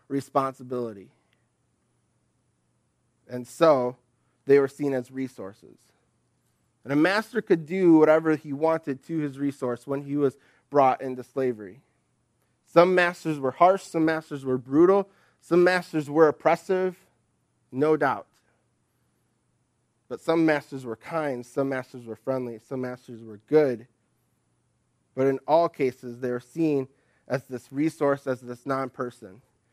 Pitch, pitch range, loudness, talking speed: 135 Hz, 125-155 Hz, -25 LUFS, 135 wpm